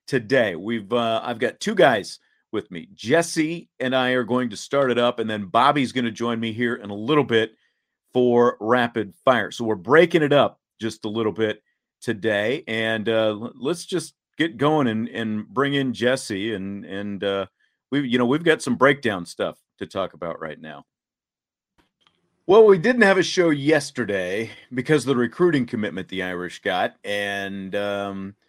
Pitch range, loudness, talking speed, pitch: 105-140 Hz, -22 LUFS, 185 wpm, 120 Hz